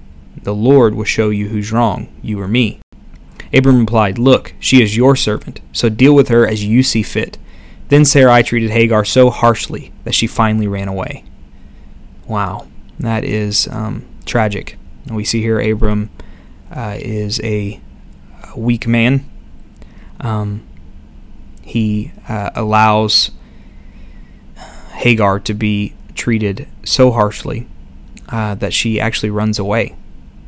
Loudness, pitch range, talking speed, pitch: -14 LUFS, 100-115 Hz, 130 wpm, 110 Hz